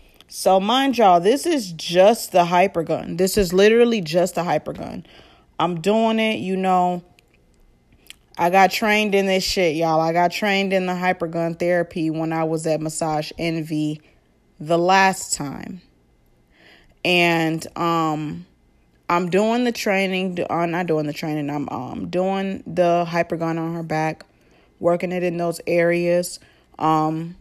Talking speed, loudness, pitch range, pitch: 160 wpm, -20 LUFS, 160-190 Hz, 175 Hz